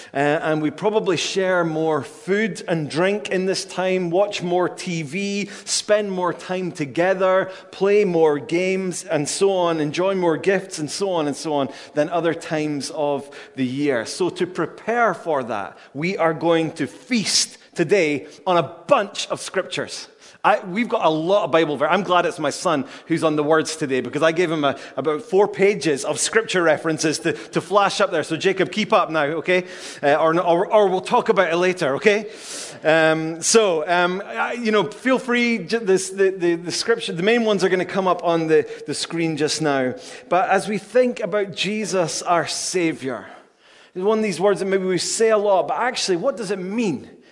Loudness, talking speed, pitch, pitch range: -20 LUFS, 200 wpm, 180 Hz, 160-200 Hz